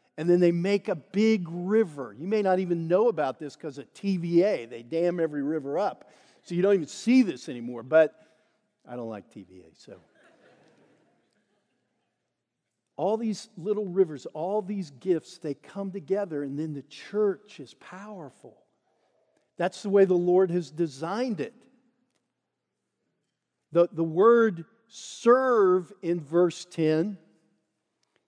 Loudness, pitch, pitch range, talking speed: -26 LUFS, 180 Hz, 155-205 Hz, 140 wpm